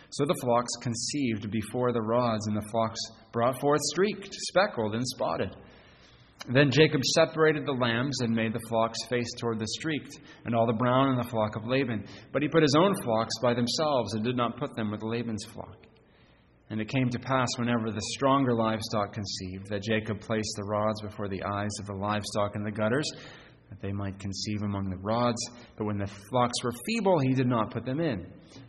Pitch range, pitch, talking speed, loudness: 105-130 Hz, 115 Hz, 205 wpm, -29 LUFS